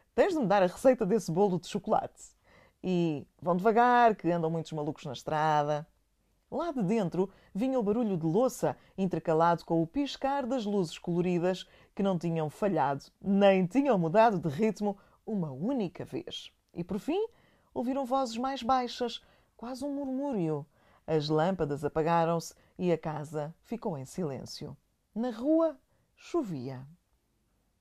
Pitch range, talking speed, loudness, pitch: 160-240 Hz, 145 wpm, -30 LUFS, 185 Hz